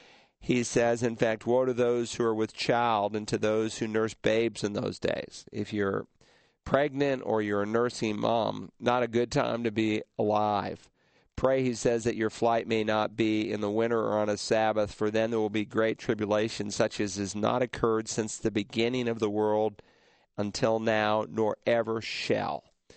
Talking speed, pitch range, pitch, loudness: 195 wpm, 105-115 Hz, 110 Hz, -29 LUFS